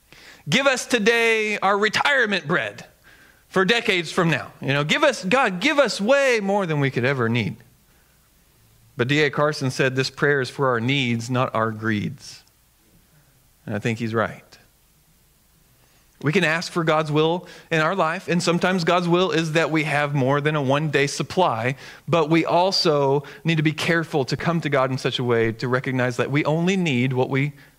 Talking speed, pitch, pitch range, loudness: 190 wpm, 150 Hz, 130-175 Hz, -21 LUFS